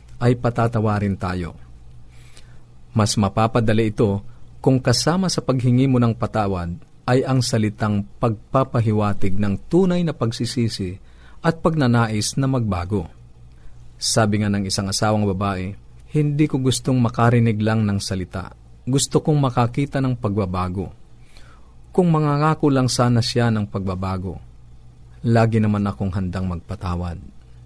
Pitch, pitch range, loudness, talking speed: 110 Hz, 95-125 Hz, -20 LUFS, 120 wpm